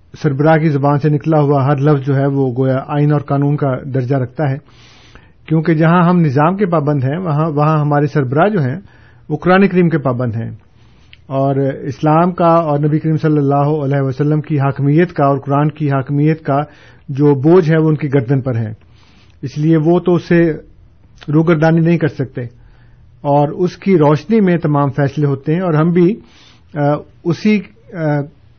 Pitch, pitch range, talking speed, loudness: 145 Hz, 135-160 Hz, 180 wpm, -14 LUFS